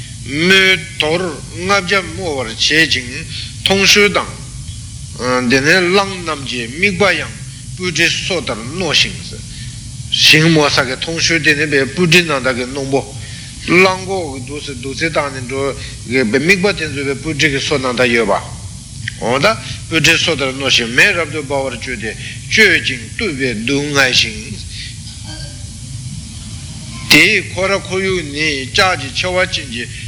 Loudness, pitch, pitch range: -13 LUFS, 135 Hz, 120-165 Hz